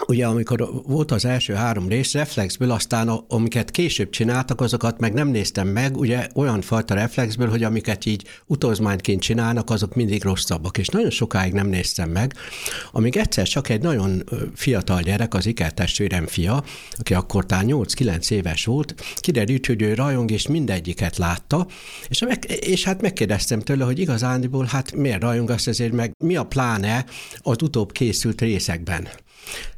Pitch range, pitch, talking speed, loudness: 100-130 Hz, 115 Hz, 160 wpm, -22 LUFS